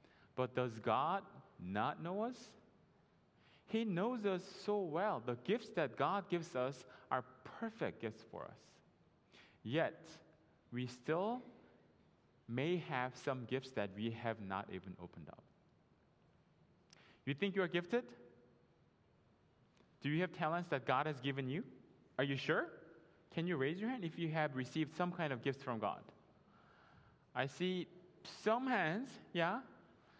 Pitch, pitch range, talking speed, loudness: 155 Hz, 125-185 Hz, 145 wpm, -41 LUFS